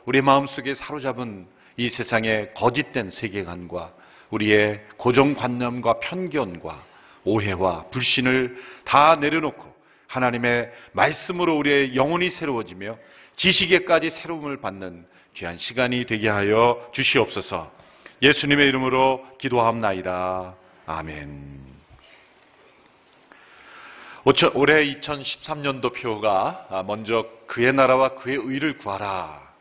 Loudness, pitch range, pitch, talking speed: -22 LUFS, 100-140 Hz, 125 Hz, 250 characters per minute